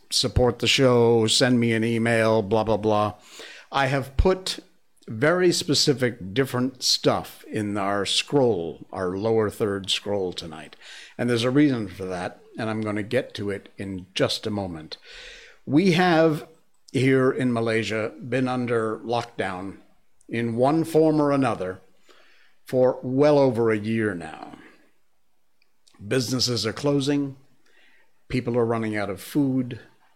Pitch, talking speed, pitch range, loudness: 120 Hz, 140 wpm, 105-135 Hz, -23 LUFS